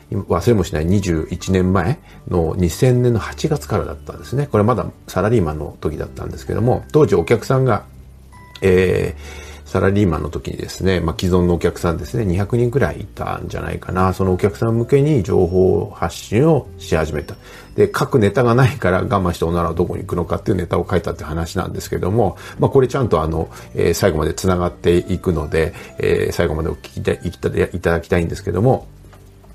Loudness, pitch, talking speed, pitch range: -18 LUFS, 95 Hz, 400 characters per minute, 85-105 Hz